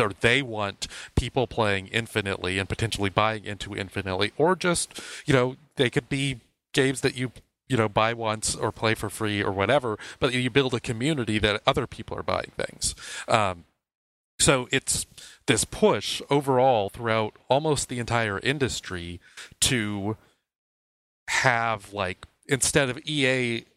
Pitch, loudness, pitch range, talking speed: 115 Hz, -25 LUFS, 100-130 Hz, 150 wpm